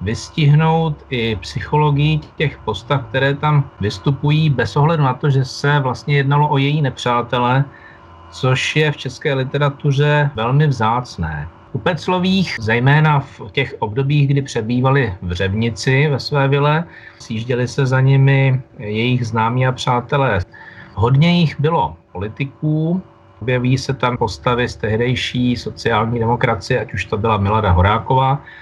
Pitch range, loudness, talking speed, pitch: 115-145 Hz, -17 LUFS, 135 wpm, 130 Hz